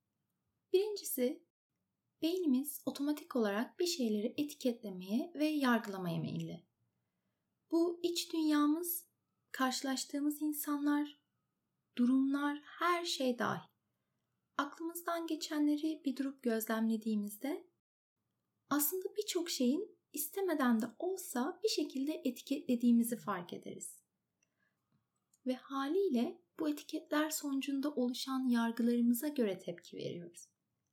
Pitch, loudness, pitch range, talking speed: 290 Hz, -36 LUFS, 245-330 Hz, 85 wpm